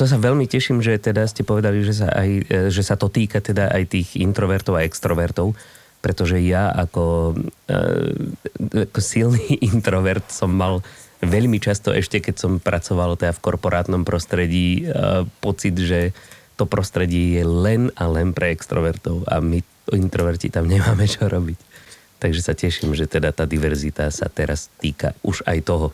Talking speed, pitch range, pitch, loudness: 160 wpm, 85-105 Hz, 95 Hz, -20 LUFS